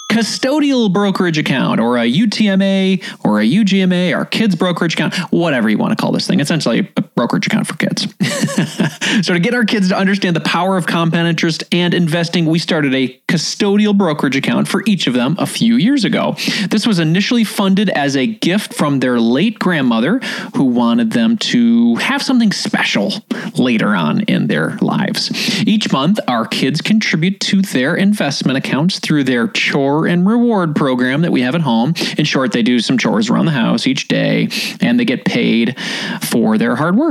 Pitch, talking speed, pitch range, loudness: 205 Hz, 190 wpm, 180-230 Hz, -14 LUFS